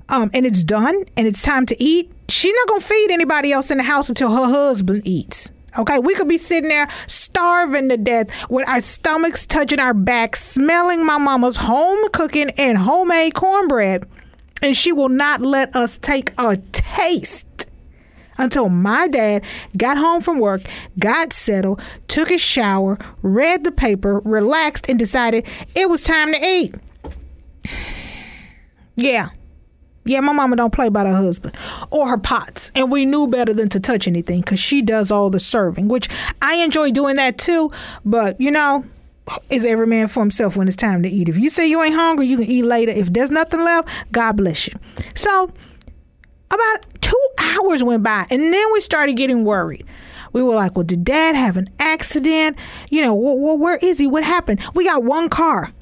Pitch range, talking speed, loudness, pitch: 215-315 Hz, 185 wpm, -16 LUFS, 260 Hz